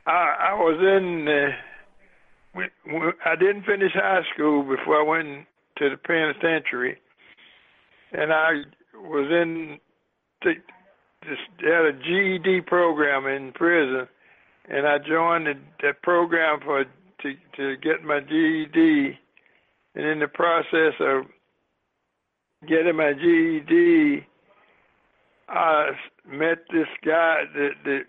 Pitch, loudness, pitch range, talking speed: 160 Hz, -22 LUFS, 145-175 Hz, 120 wpm